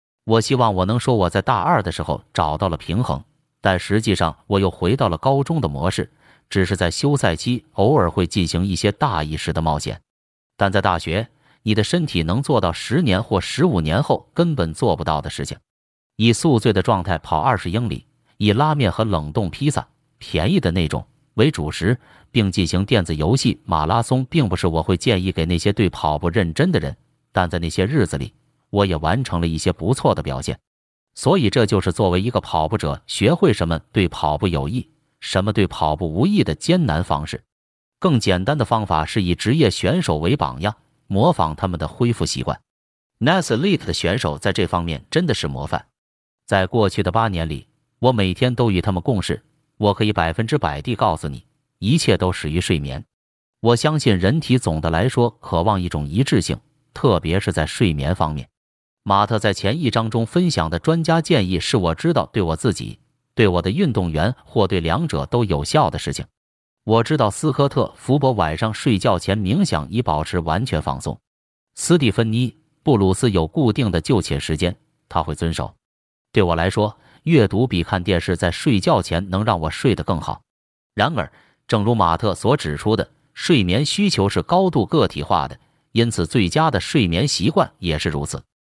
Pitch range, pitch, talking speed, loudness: 85-120 Hz, 100 Hz, 285 characters per minute, -20 LUFS